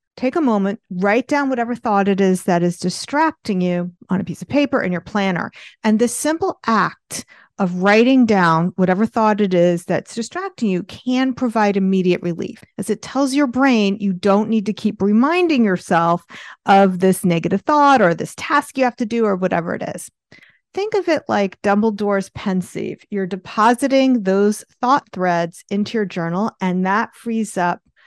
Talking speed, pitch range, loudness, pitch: 180 wpm, 185-245 Hz, -18 LUFS, 205 Hz